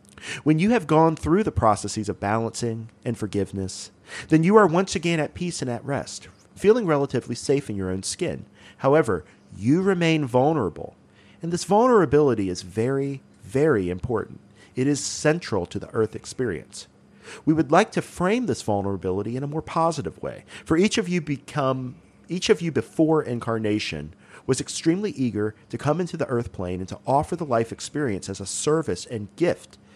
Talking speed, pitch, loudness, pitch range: 175 wpm, 135 Hz, -24 LUFS, 105-160 Hz